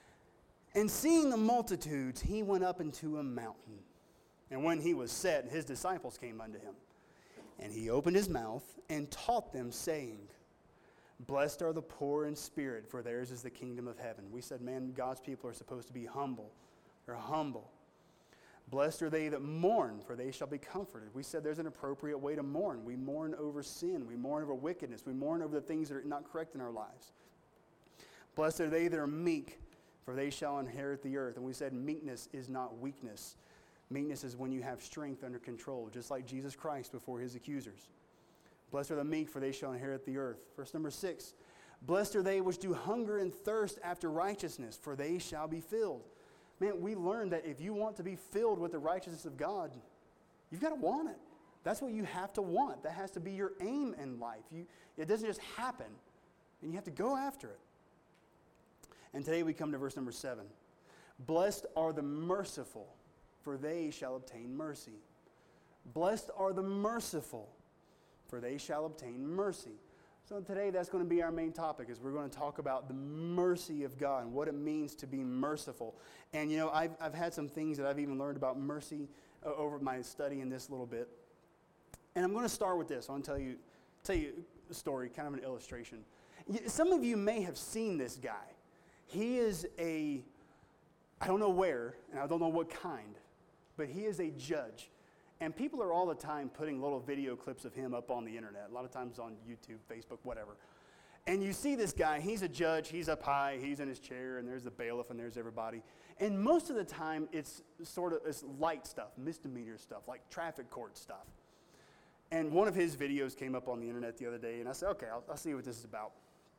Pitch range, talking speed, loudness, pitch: 130-175 Hz, 210 wpm, -39 LUFS, 150 Hz